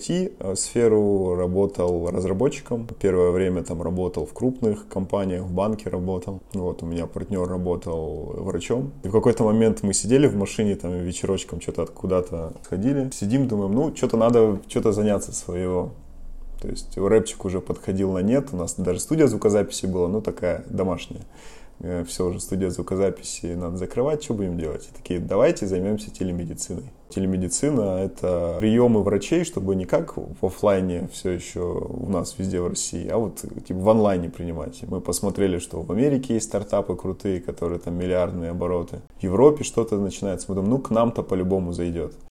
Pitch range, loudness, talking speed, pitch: 90-105 Hz, -24 LUFS, 165 wpm, 95 Hz